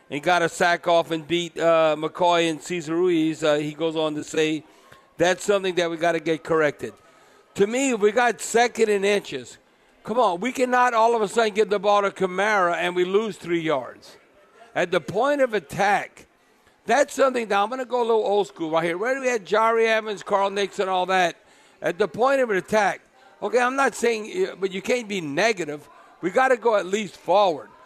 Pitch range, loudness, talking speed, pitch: 170-230 Hz, -22 LUFS, 220 wpm, 200 Hz